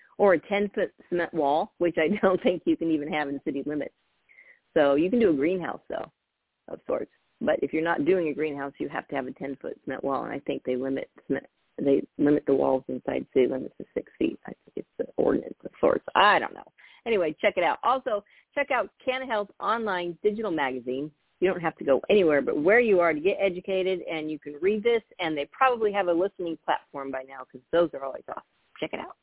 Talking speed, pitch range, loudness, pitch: 235 wpm, 145-195 Hz, -27 LUFS, 170 Hz